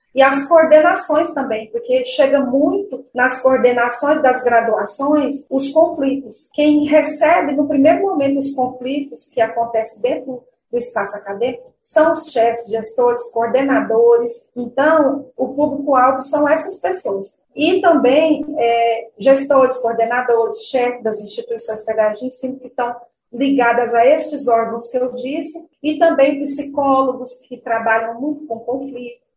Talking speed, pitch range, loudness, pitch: 130 wpm, 240-300 Hz, -16 LUFS, 260 Hz